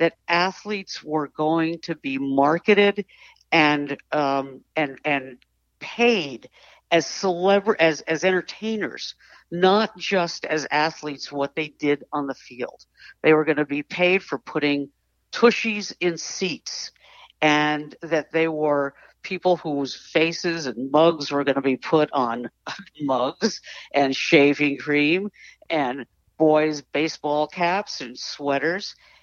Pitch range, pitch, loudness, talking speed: 140-175 Hz, 155 Hz, -22 LUFS, 130 wpm